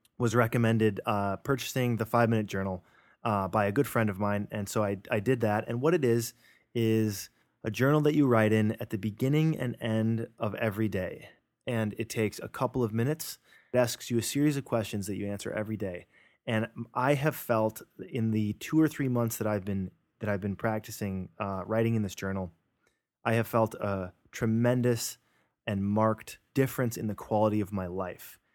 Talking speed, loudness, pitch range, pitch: 200 wpm, -30 LUFS, 105-120 Hz, 110 Hz